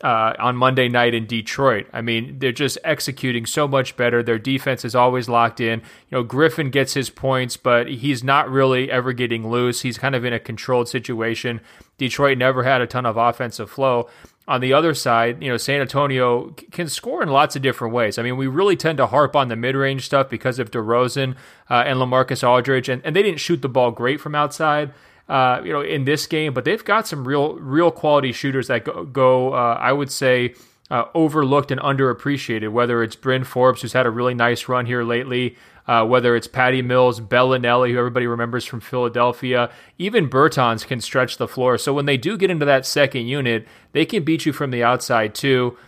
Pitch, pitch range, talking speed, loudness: 130 Hz, 120-140 Hz, 210 wpm, -19 LUFS